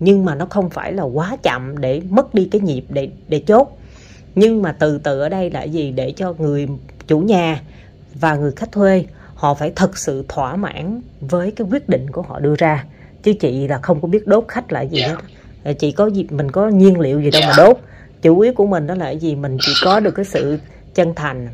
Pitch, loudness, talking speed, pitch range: 160 Hz, -16 LUFS, 235 wpm, 145-195 Hz